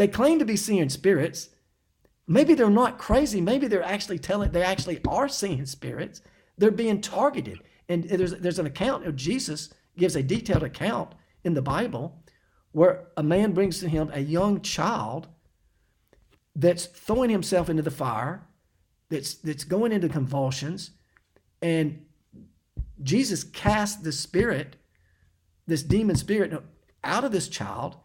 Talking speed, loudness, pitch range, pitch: 145 wpm, -25 LUFS, 155-205 Hz, 180 Hz